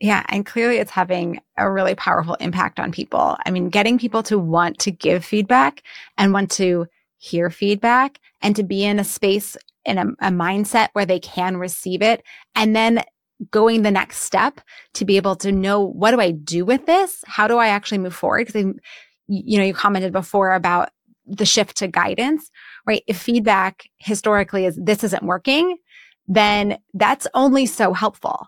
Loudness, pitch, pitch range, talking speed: -19 LUFS, 205 Hz, 190-230 Hz, 185 wpm